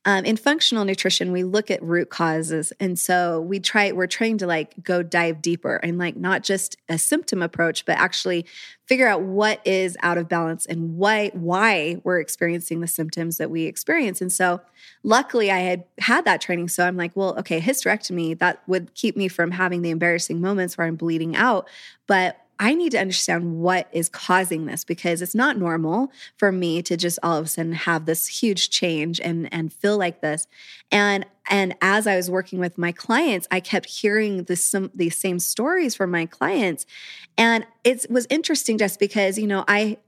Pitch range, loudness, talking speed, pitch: 170-205 Hz, -21 LUFS, 195 wpm, 185 Hz